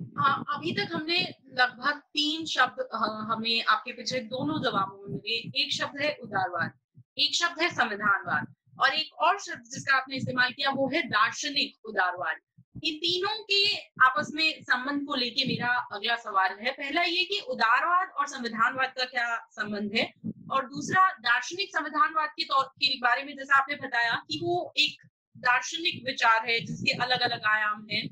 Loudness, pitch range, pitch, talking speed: -27 LUFS, 230-310 Hz, 265 Hz, 165 wpm